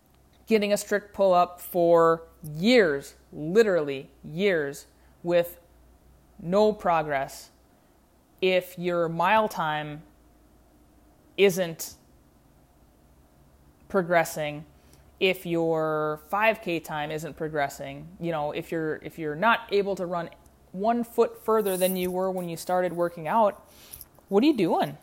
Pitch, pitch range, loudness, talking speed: 170 Hz, 150-190 Hz, -26 LUFS, 115 wpm